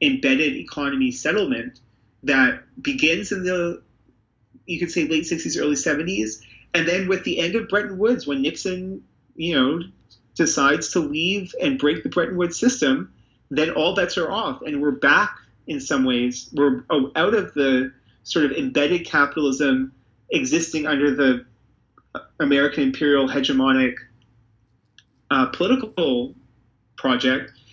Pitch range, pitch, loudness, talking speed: 125-180 Hz, 145 Hz, -21 LUFS, 135 wpm